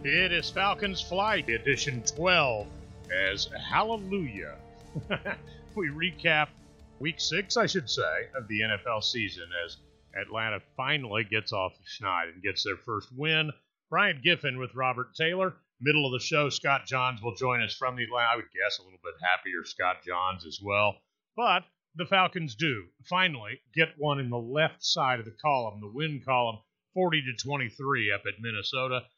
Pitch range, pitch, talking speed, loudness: 115-160 Hz, 130 Hz, 165 wpm, -29 LUFS